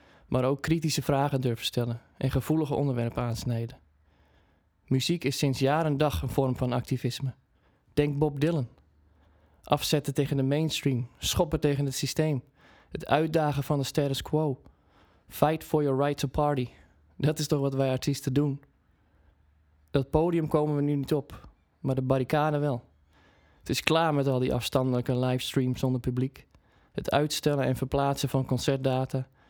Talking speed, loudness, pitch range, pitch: 155 wpm, -28 LUFS, 120-145 Hz, 135 Hz